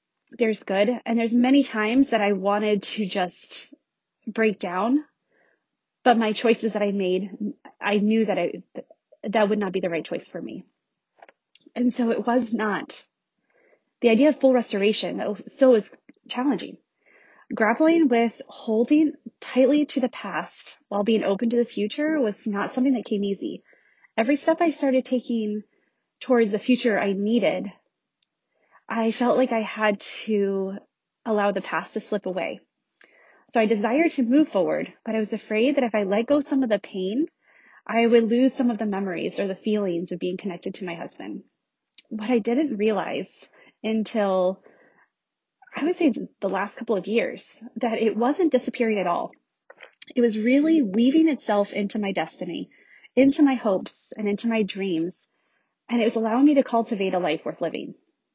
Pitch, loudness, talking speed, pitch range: 225 Hz, -24 LUFS, 170 wpm, 205-260 Hz